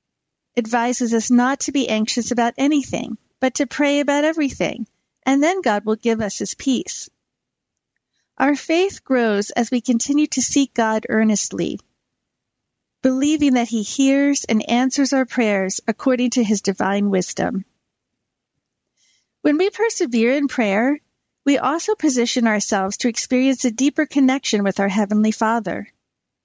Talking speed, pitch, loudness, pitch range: 140 wpm, 245 Hz, -19 LUFS, 220-280 Hz